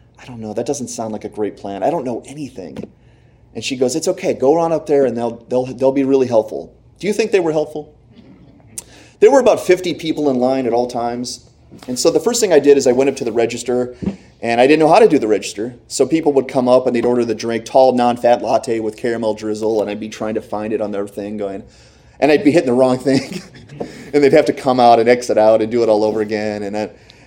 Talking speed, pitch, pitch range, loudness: 265 wpm, 120 Hz, 110-135 Hz, -16 LUFS